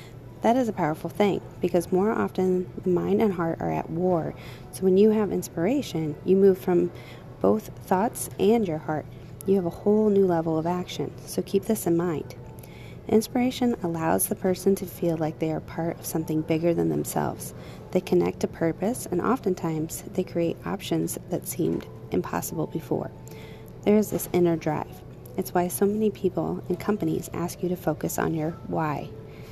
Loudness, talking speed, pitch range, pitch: -26 LUFS, 180 wpm, 160-195 Hz, 175 Hz